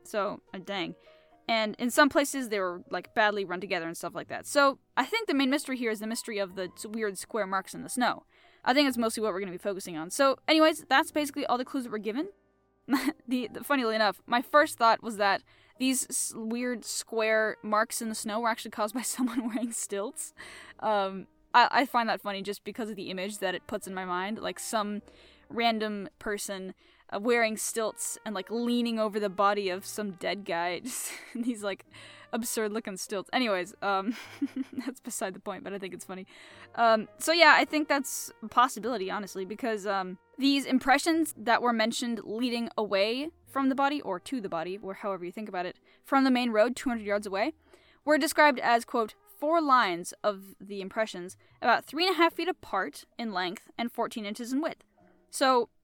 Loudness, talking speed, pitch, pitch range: -29 LUFS, 205 wpm, 225 Hz, 200-260 Hz